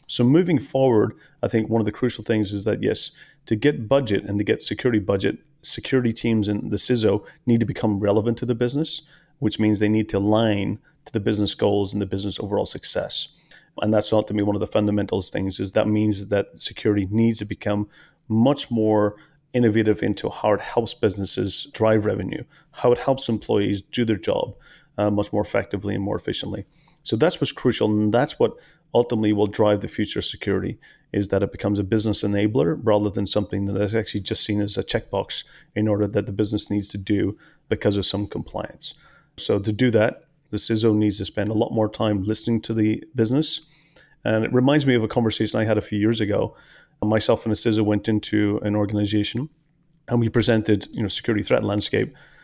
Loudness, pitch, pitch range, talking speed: -22 LUFS, 105 Hz, 105-115 Hz, 205 wpm